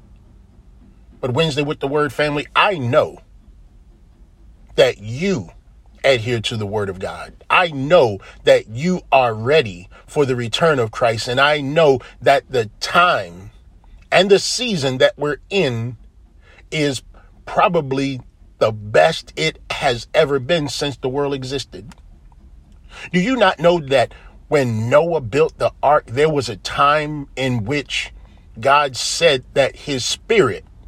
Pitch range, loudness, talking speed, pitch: 100-150 Hz, -18 LUFS, 140 wpm, 135 Hz